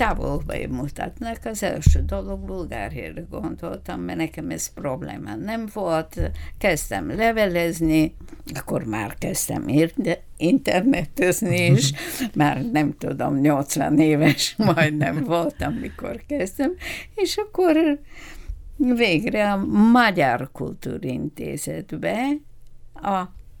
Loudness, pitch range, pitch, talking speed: -22 LUFS, 145-230 Hz, 165 Hz, 95 wpm